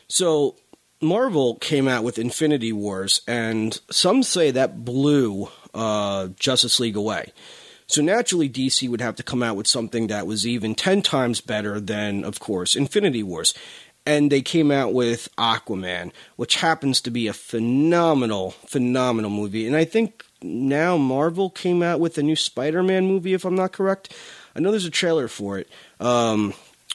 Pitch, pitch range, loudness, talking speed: 125 Hz, 110-160 Hz, -21 LUFS, 170 wpm